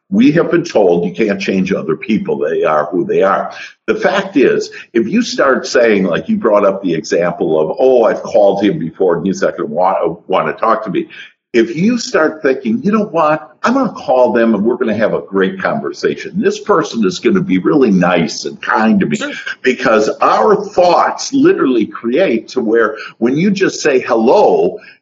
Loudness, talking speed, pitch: -13 LUFS, 210 wpm, 195 Hz